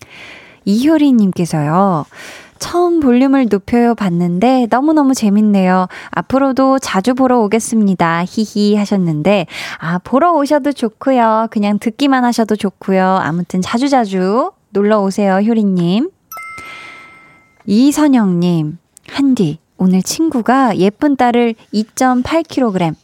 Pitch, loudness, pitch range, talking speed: 225 Hz, -13 LUFS, 190-265 Hz, 255 characters per minute